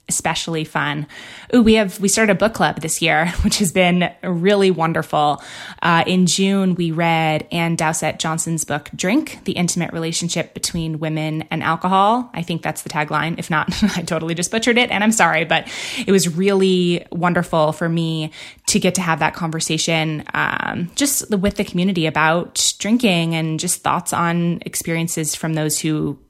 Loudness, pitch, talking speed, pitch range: -18 LUFS, 170 Hz, 175 wpm, 160-190 Hz